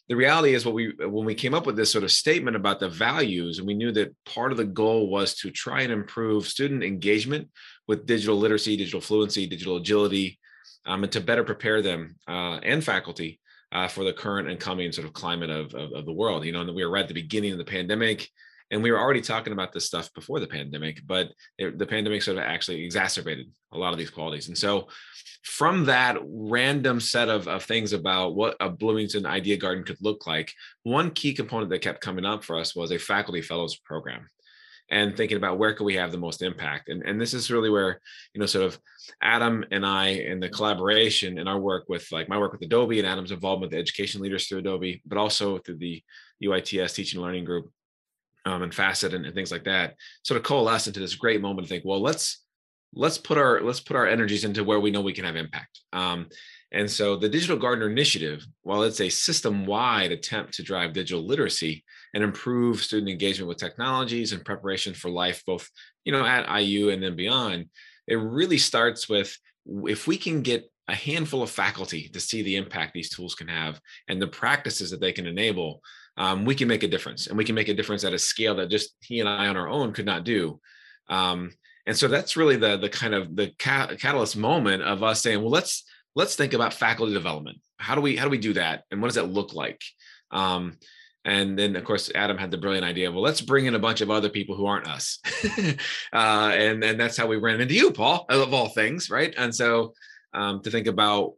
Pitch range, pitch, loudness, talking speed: 90-110 Hz, 105 Hz, -25 LUFS, 225 wpm